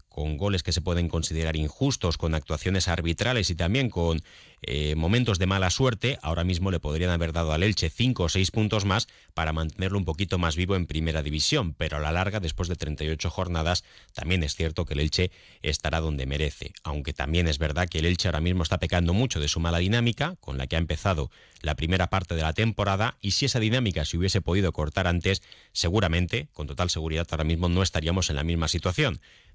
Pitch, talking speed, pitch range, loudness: 85 Hz, 215 wpm, 80-95 Hz, -26 LUFS